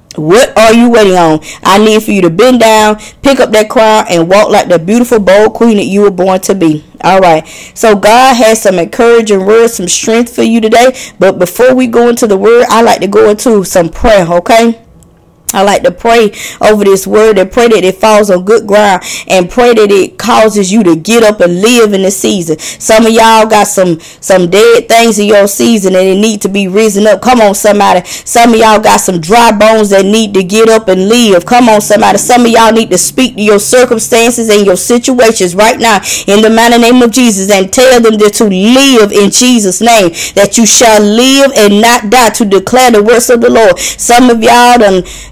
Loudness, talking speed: -5 LUFS, 225 wpm